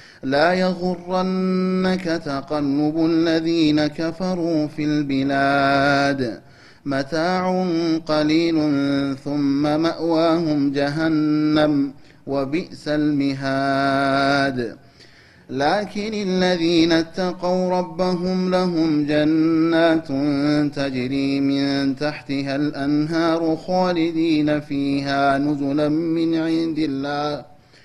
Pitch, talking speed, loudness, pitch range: 150 Hz, 65 wpm, -20 LUFS, 140-165 Hz